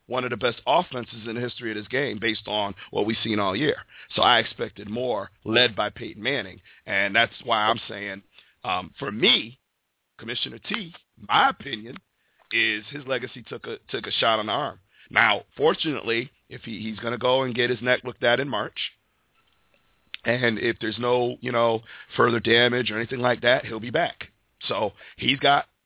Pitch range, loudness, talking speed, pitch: 110-125 Hz, -24 LUFS, 190 wpm, 120 Hz